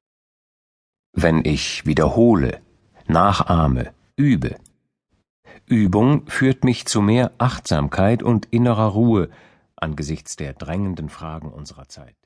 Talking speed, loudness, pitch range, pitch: 100 wpm, -19 LUFS, 75-115 Hz, 95 Hz